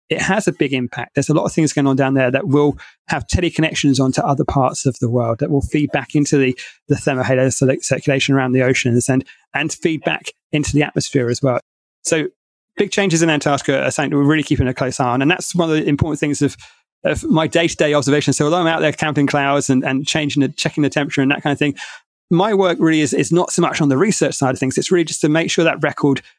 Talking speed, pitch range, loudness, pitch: 265 wpm, 135-160 Hz, -17 LUFS, 145 Hz